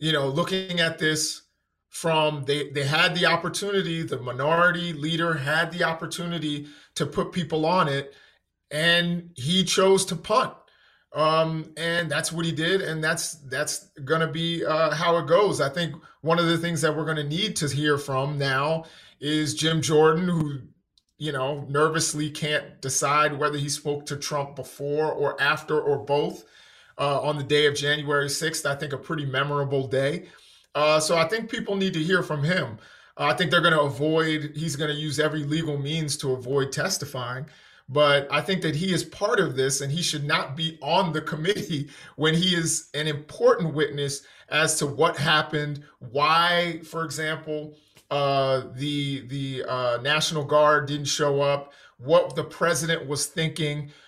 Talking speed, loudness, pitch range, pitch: 175 wpm, -24 LUFS, 145-165 Hz, 155 Hz